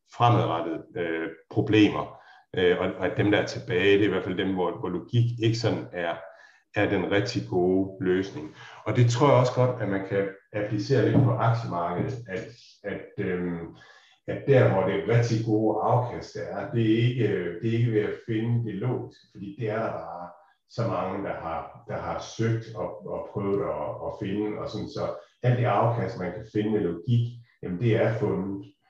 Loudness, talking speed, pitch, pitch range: -26 LUFS, 205 wpm, 110 Hz, 100-120 Hz